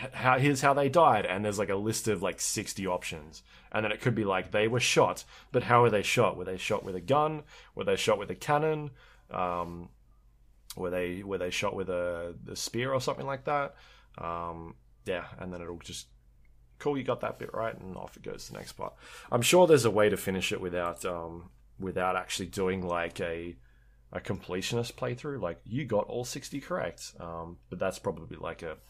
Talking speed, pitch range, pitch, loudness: 215 wpm, 85-130 Hz, 95 Hz, -30 LUFS